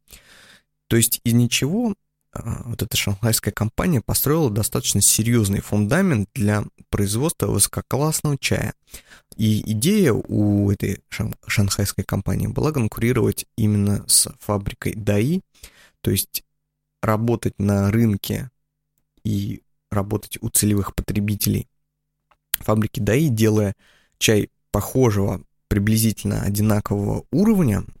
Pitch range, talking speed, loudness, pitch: 100-130 Hz, 100 wpm, -21 LUFS, 110 Hz